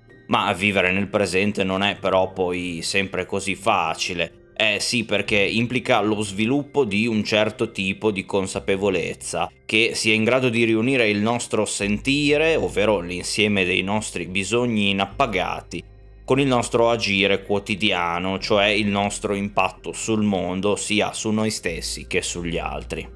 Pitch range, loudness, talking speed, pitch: 95-110 Hz, -21 LUFS, 145 wpm, 100 Hz